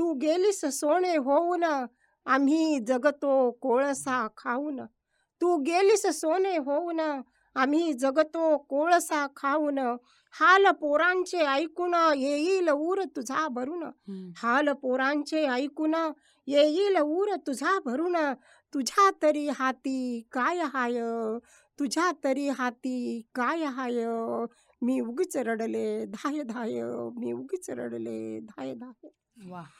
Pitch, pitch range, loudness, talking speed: 285 Hz, 245-320 Hz, -27 LUFS, 105 wpm